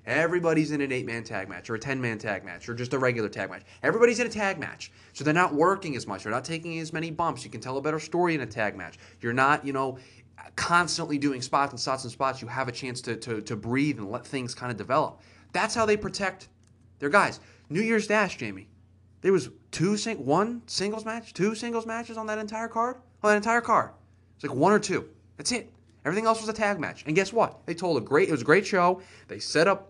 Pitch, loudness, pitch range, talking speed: 150 Hz, -27 LUFS, 120-200 Hz, 255 wpm